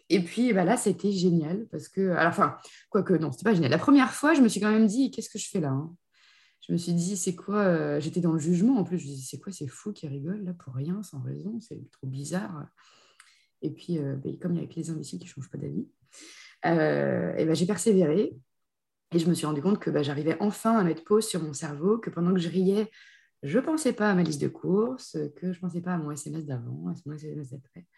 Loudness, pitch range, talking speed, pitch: -27 LUFS, 150-205 Hz, 265 wpm, 175 Hz